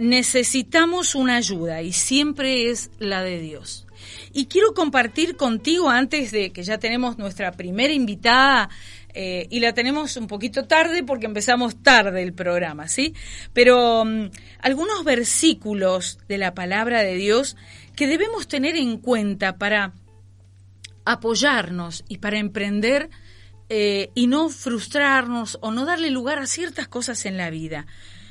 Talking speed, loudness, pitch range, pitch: 140 wpm, -20 LUFS, 185-270 Hz, 235 Hz